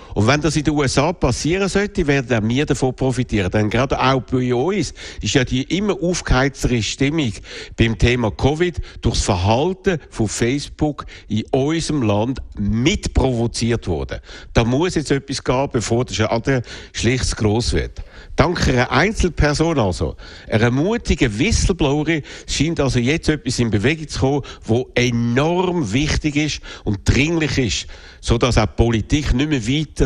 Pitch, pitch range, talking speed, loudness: 130 Hz, 110-150 Hz, 150 wpm, -19 LUFS